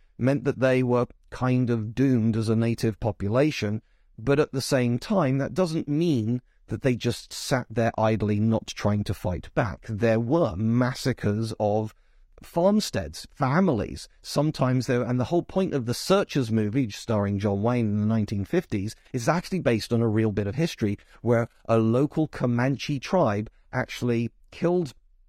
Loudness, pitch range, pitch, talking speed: -25 LUFS, 110-140 Hz, 120 Hz, 160 wpm